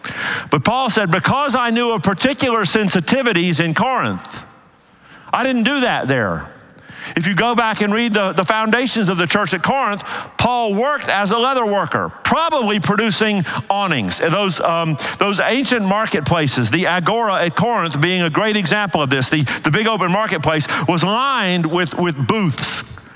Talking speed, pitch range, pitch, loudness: 165 wpm, 170-230 Hz, 200 Hz, -16 LUFS